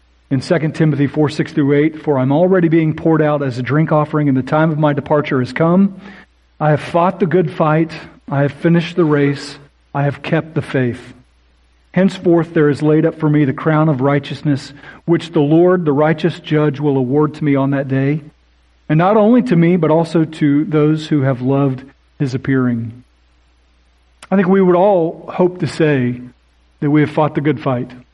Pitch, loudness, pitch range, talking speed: 150 Hz, -15 LUFS, 135-165 Hz, 200 wpm